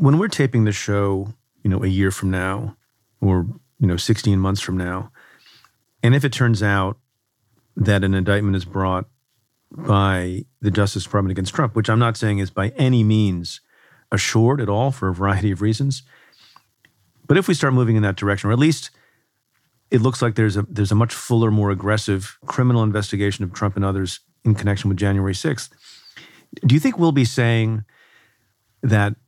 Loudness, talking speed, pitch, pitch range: -20 LUFS, 185 wpm, 105 Hz, 100-120 Hz